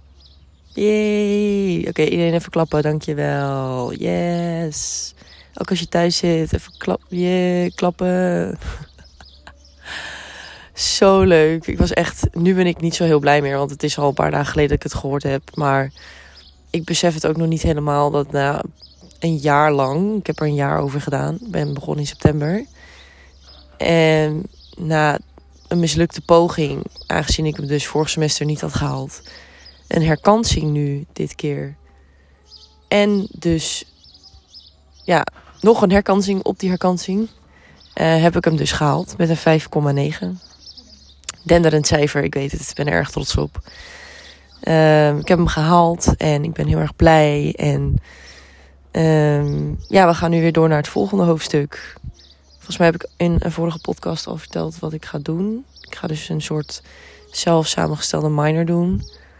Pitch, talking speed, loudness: 150 Hz, 165 wpm, -18 LUFS